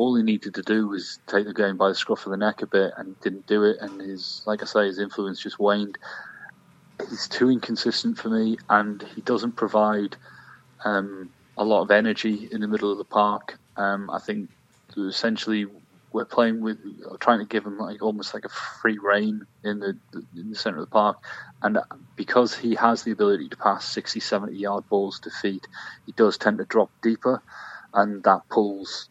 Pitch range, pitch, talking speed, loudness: 100-110 Hz, 105 Hz, 200 wpm, -24 LUFS